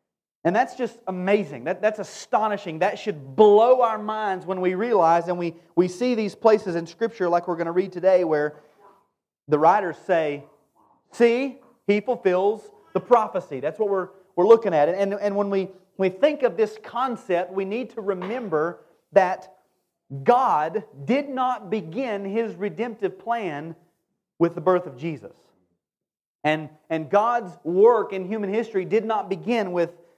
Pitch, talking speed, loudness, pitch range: 195 Hz, 165 wpm, -23 LUFS, 175-220 Hz